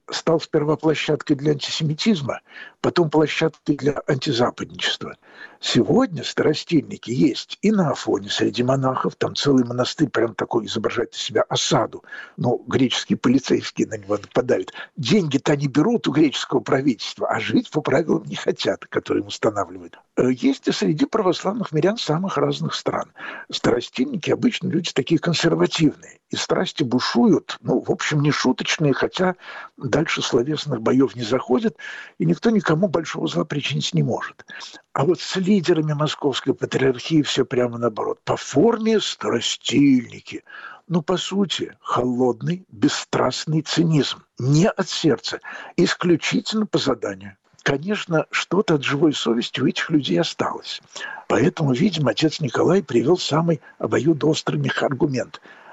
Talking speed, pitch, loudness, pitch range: 130 wpm, 160 Hz, -21 LUFS, 140-185 Hz